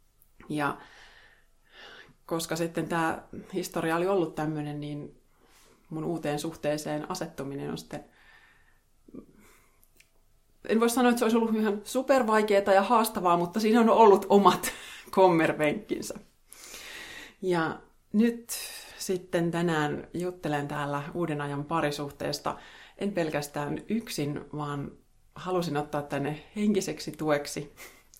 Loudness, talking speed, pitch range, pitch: -28 LUFS, 105 wpm, 150-205 Hz, 170 Hz